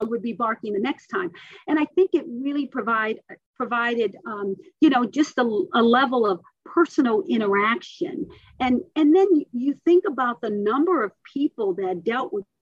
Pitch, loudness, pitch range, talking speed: 275 Hz, -23 LUFS, 235-345 Hz, 170 wpm